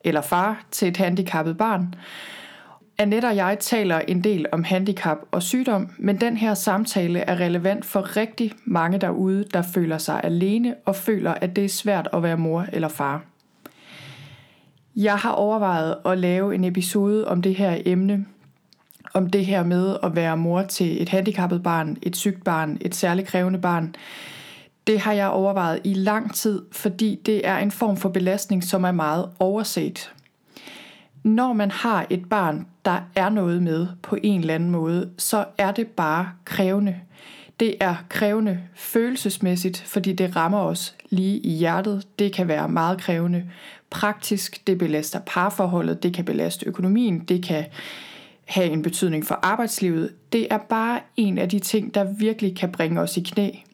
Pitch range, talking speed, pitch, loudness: 175-205 Hz, 170 wpm, 190 Hz, -23 LUFS